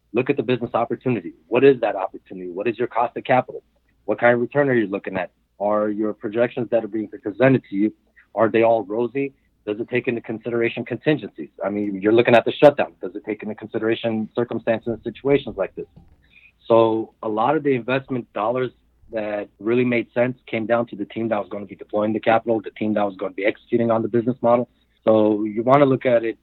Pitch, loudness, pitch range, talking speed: 115 Hz, -21 LUFS, 110-120 Hz, 230 wpm